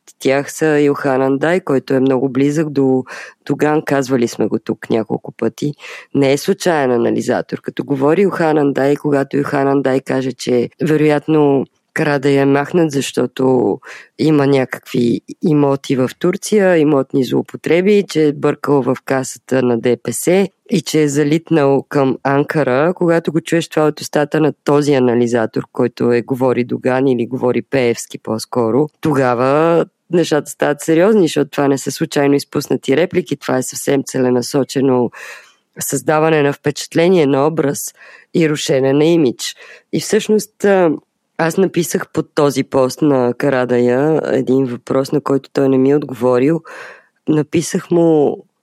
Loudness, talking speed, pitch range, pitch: -15 LUFS, 140 wpm, 130-155 Hz, 140 Hz